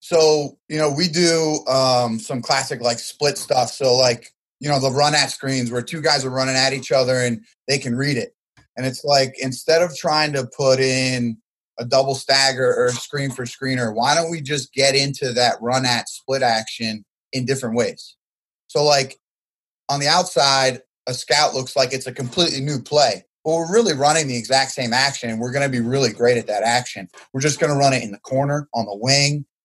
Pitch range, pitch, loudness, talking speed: 125-145 Hz, 135 Hz, -19 LUFS, 215 wpm